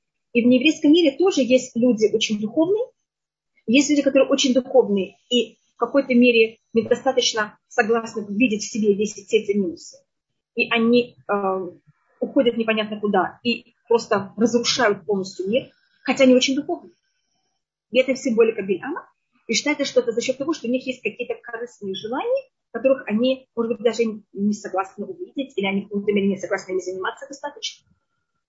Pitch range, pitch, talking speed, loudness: 210-265 Hz, 235 Hz, 160 wpm, -21 LUFS